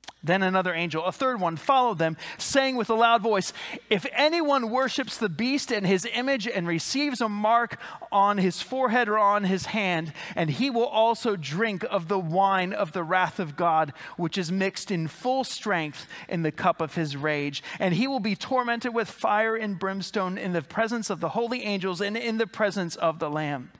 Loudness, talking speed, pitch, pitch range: -26 LUFS, 200 wpm, 205 Hz, 175-235 Hz